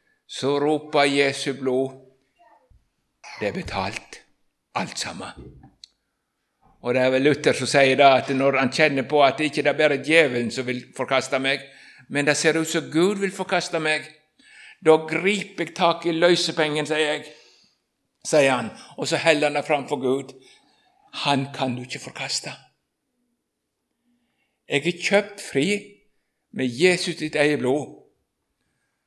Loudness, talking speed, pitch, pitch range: -22 LUFS, 150 wpm, 150 Hz, 135-170 Hz